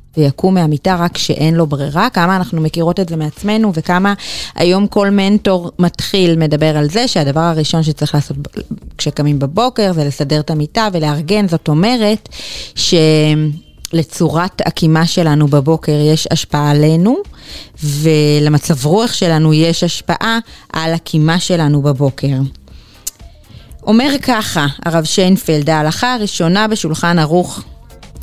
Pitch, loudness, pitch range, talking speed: 165 Hz, -13 LUFS, 150-185 Hz, 120 wpm